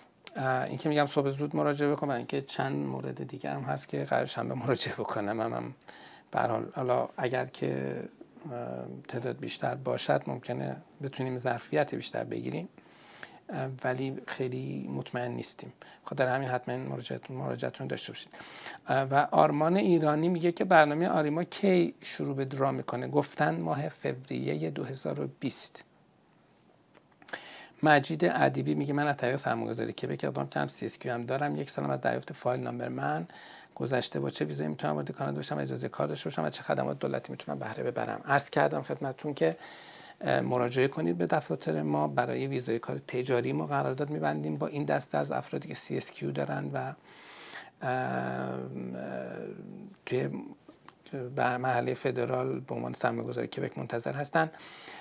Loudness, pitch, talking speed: -31 LUFS, 115 Hz, 145 wpm